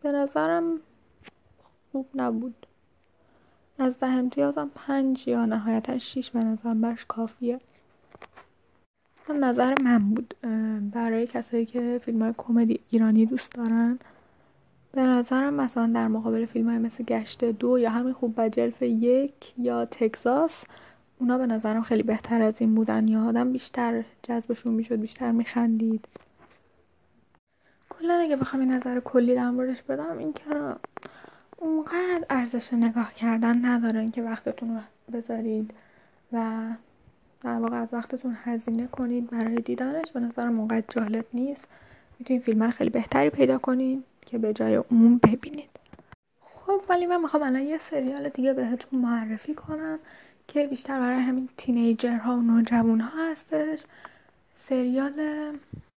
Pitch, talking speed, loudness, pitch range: 245 Hz, 135 wpm, -26 LUFS, 230-270 Hz